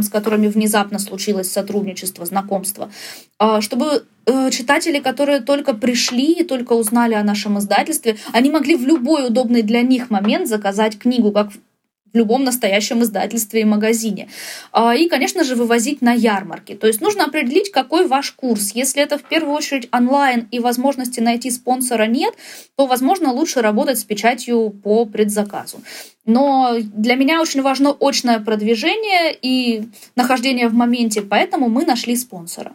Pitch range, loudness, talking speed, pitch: 215-275 Hz, -17 LUFS, 150 wpm, 240 Hz